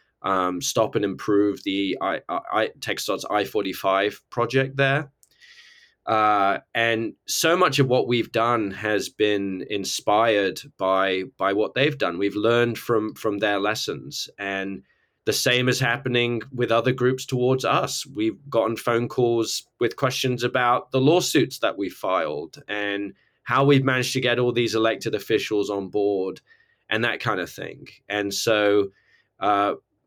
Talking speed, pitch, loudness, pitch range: 150 wpm, 115 Hz, -23 LUFS, 100-130 Hz